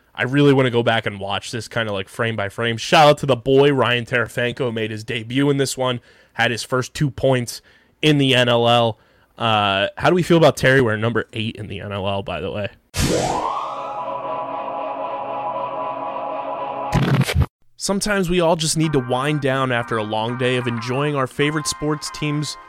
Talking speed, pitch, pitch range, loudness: 185 wpm, 130 Hz, 115-150 Hz, -20 LUFS